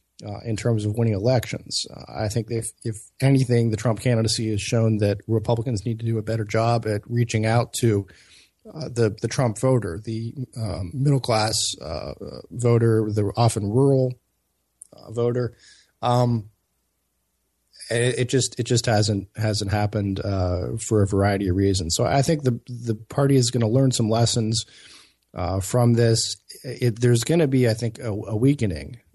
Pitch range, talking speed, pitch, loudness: 105-125 Hz, 175 wpm, 115 Hz, -23 LUFS